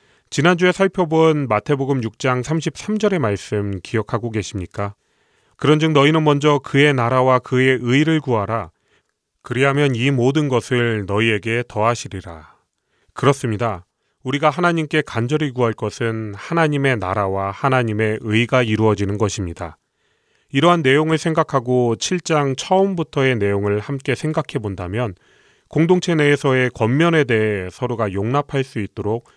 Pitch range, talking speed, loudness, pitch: 110-150 Hz, 310 characters per minute, -18 LUFS, 130 Hz